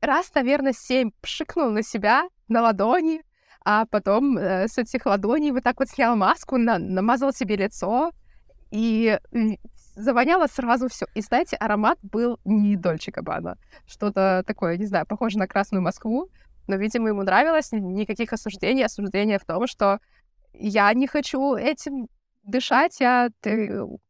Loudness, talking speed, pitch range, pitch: -23 LUFS, 150 wpm, 205-260 Hz, 225 Hz